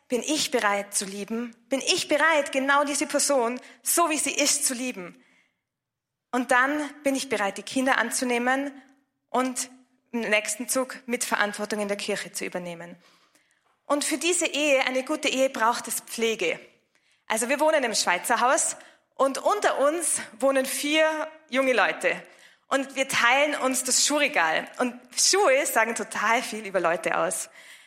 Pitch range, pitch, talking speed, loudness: 230-290 Hz, 260 Hz, 155 wpm, -24 LUFS